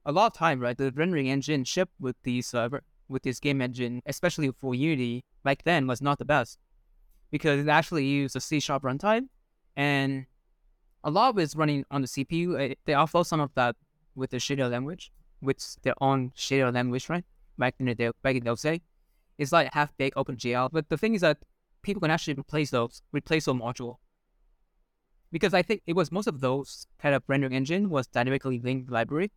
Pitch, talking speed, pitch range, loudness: 140 Hz, 195 wpm, 130-160 Hz, -28 LUFS